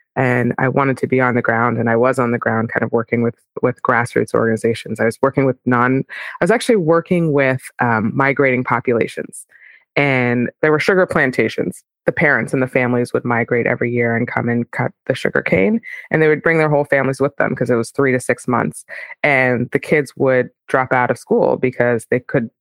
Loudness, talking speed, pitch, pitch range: -17 LUFS, 220 wpm, 125 Hz, 120-140 Hz